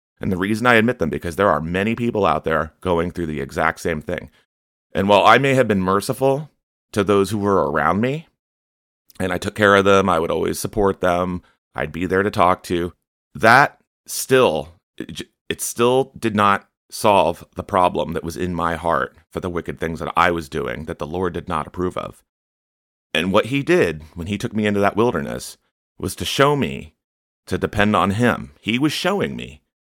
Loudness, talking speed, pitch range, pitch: -19 LUFS, 205 wpm, 85-105 Hz, 95 Hz